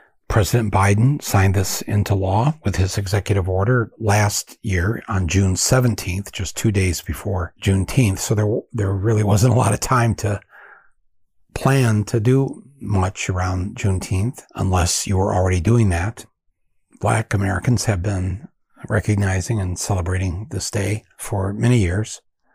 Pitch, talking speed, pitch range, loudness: 100 Hz, 145 wpm, 95-110 Hz, -20 LUFS